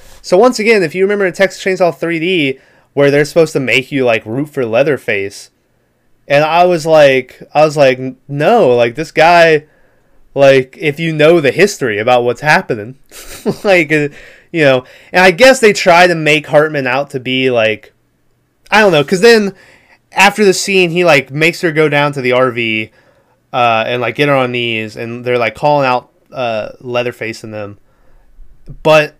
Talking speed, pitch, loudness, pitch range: 185 wpm, 145 Hz, -11 LUFS, 125-170 Hz